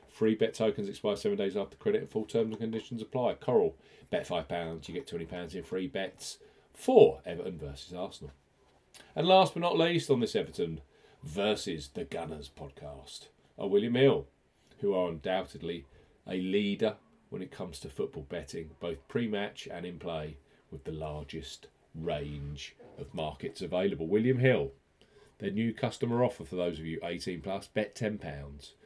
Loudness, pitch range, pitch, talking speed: -32 LUFS, 80-125 Hz, 105 Hz, 165 wpm